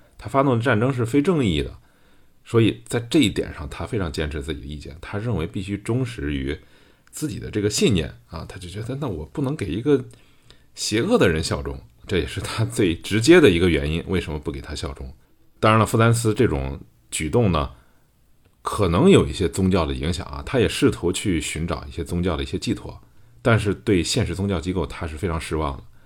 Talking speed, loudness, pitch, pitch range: 310 characters per minute, -22 LUFS, 90 Hz, 75-110 Hz